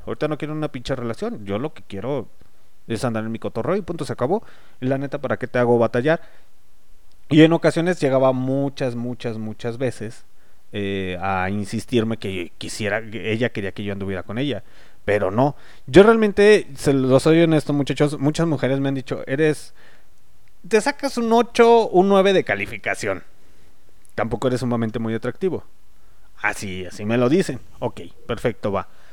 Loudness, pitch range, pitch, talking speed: -21 LUFS, 110-150 Hz, 125 Hz, 170 wpm